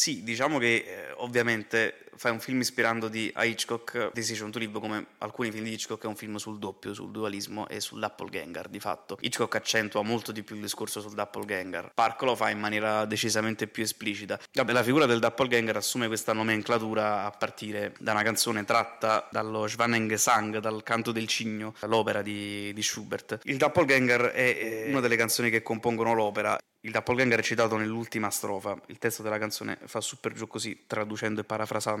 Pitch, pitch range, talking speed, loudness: 110 Hz, 105-115 Hz, 190 wpm, -29 LUFS